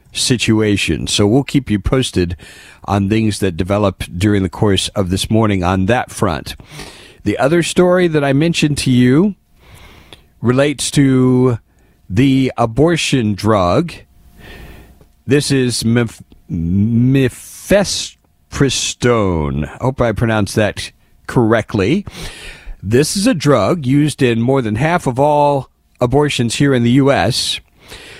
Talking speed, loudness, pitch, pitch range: 120 wpm, -14 LUFS, 115 Hz, 100-135 Hz